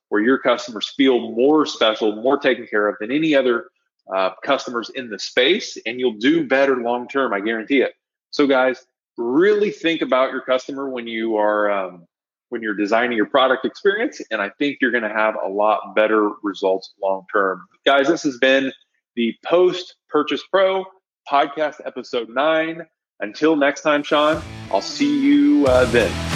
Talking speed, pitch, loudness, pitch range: 175 wpm, 130 Hz, -19 LUFS, 110-155 Hz